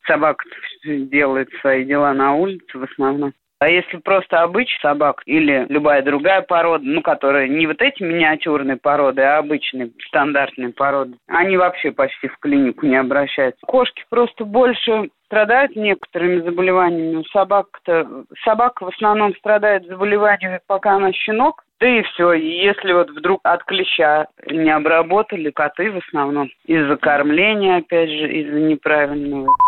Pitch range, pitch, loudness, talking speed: 145-200 Hz, 170 Hz, -17 LUFS, 140 wpm